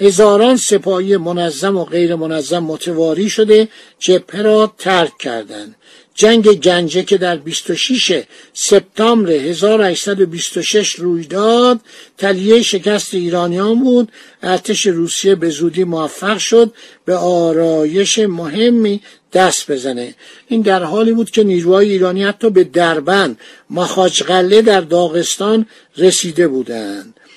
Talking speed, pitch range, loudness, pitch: 110 wpm, 175-215 Hz, -13 LUFS, 190 Hz